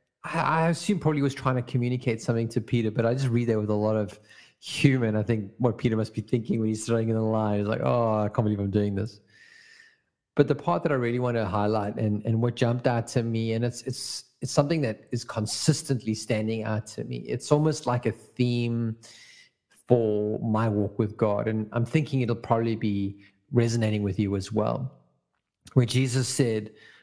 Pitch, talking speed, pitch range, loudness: 115 Hz, 210 wpm, 110-125 Hz, -27 LUFS